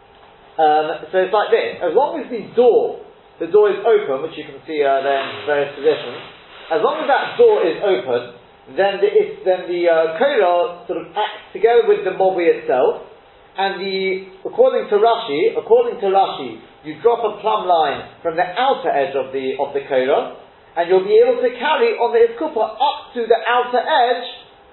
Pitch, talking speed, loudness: 235 Hz, 190 wpm, -17 LUFS